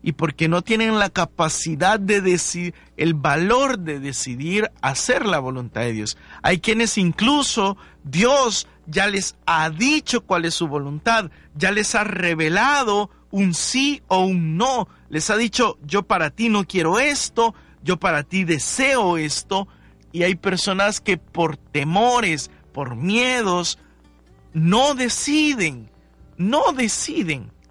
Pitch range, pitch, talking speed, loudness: 160-225 Hz, 185 Hz, 140 wpm, -20 LUFS